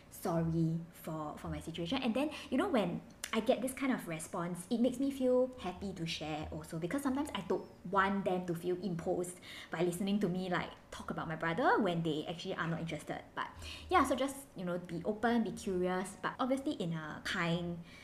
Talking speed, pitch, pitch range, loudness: 210 wpm, 185 Hz, 170-240 Hz, -36 LUFS